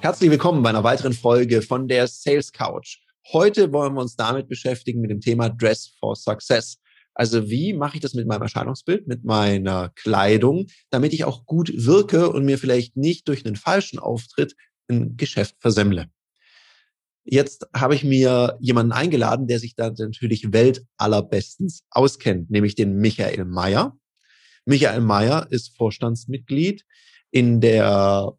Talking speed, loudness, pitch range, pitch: 150 wpm, -20 LUFS, 110-145 Hz, 125 Hz